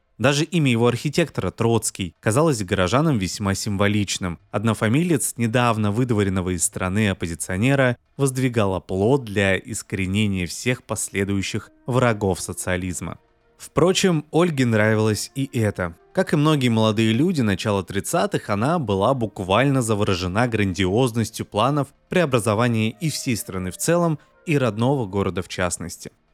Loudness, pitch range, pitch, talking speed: -21 LUFS, 100-130 Hz, 110 Hz, 120 wpm